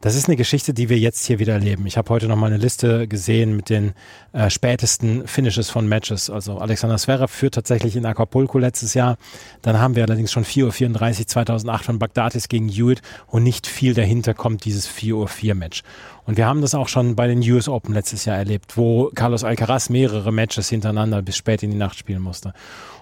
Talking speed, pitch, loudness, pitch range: 210 wpm, 115 Hz, -19 LUFS, 110-120 Hz